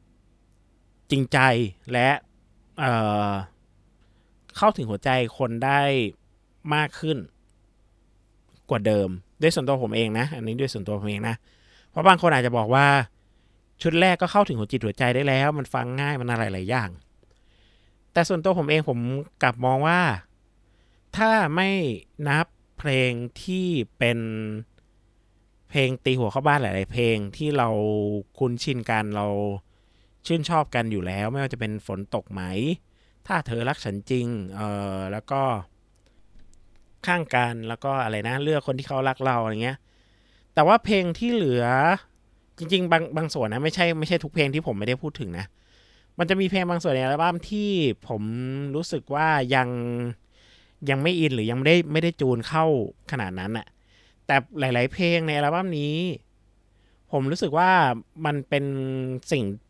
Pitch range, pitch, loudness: 105-150 Hz, 125 Hz, -24 LUFS